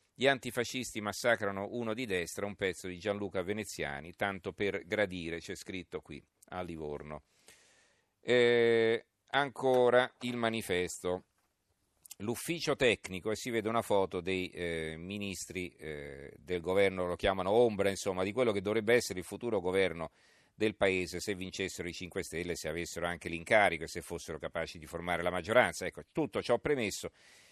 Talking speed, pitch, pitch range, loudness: 155 wpm, 95 Hz, 90-110 Hz, -33 LUFS